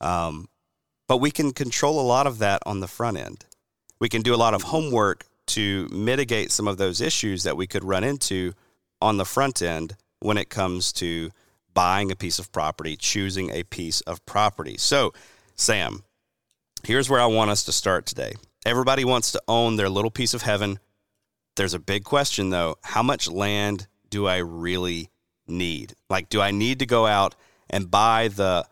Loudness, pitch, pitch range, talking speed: -23 LUFS, 100 Hz, 90-115 Hz, 190 wpm